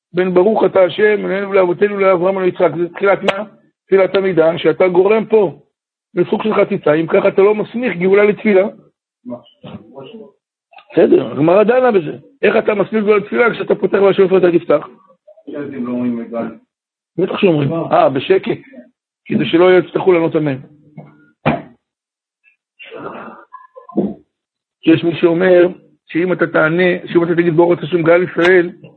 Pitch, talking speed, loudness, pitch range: 185 Hz, 140 wpm, -14 LUFS, 170-205 Hz